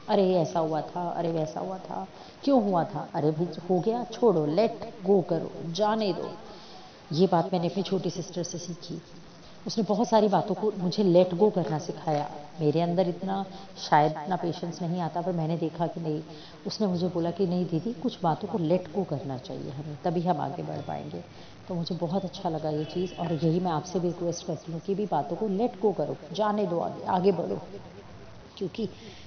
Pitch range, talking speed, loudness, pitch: 165-195 Hz, 200 wpm, -28 LUFS, 175 Hz